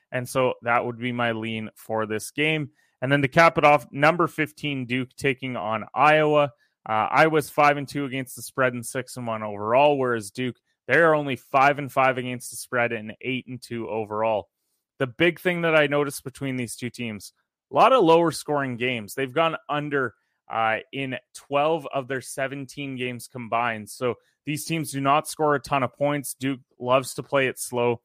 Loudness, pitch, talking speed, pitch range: -24 LUFS, 130 Hz, 200 wpm, 120-145 Hz